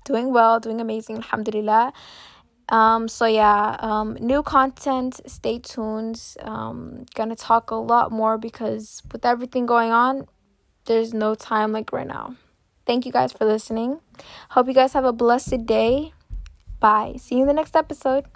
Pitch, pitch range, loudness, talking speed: 230 Hz, 220-255 Hz, -21 LUFS, 160 wpm